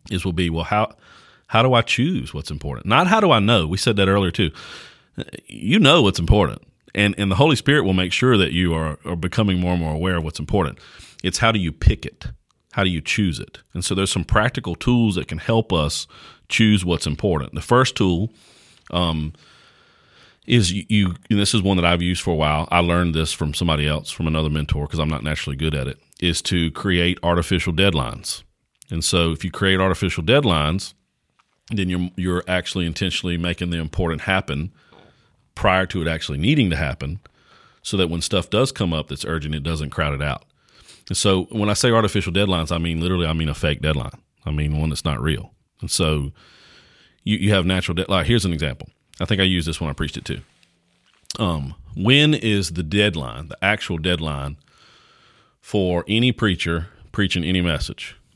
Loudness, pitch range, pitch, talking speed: -20 LUFS, 80-100 Hz, 90 Hz, 205 wpm